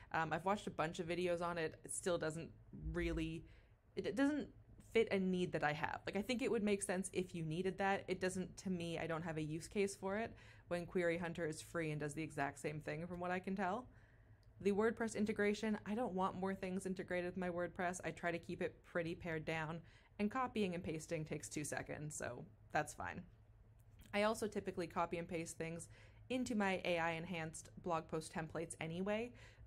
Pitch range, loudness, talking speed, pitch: 155-190 Hz, -42 LUFS, 215 wpm, 170 Hz